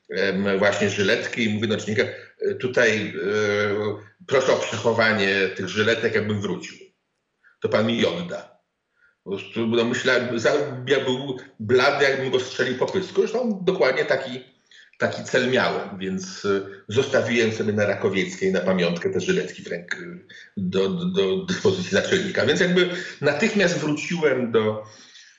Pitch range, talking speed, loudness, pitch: 105-150 Hz, 140 wpm, -22 LUFS, 115 Hz